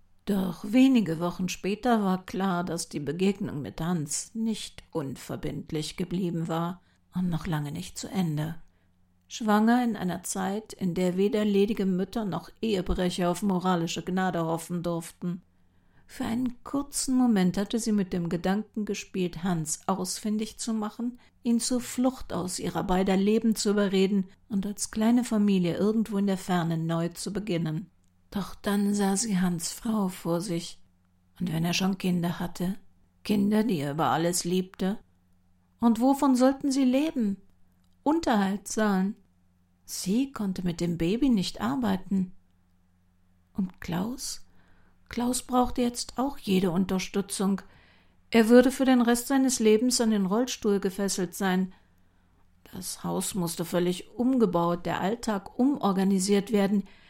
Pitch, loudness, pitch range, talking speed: 190 Hz, -27 LUFS, 170-215 Hz, 140 wpm